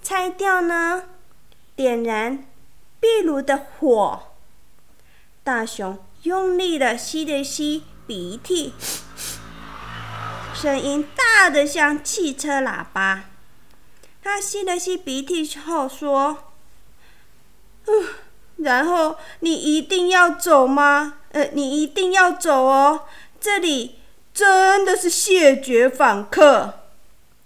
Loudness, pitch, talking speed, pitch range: -19 LUFS, 300 Hz, 135 characters per minute, 275-360 Hz